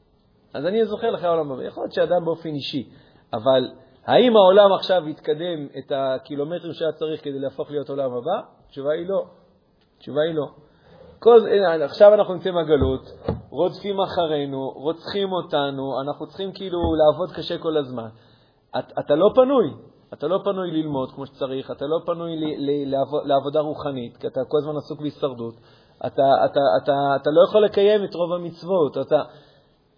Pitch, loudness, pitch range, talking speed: 150 Hz, -21 LUFS, 140-175 Hz, 160 wpm